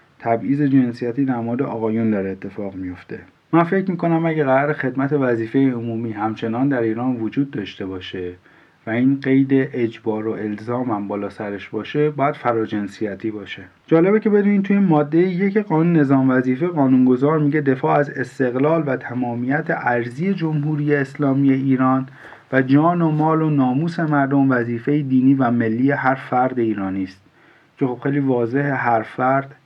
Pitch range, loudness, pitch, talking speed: 115-145 Hz, -19 LUFS, 130 Hz, 155 wpm